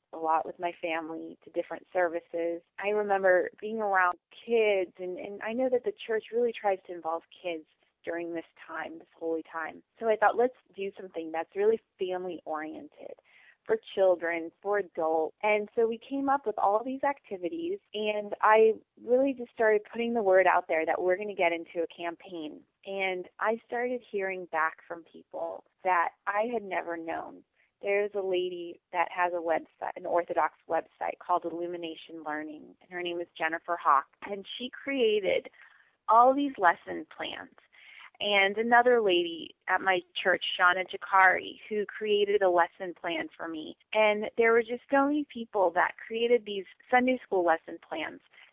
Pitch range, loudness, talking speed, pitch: 170-230 Hz, -29 LUFS, 170 wpm, 195 Hz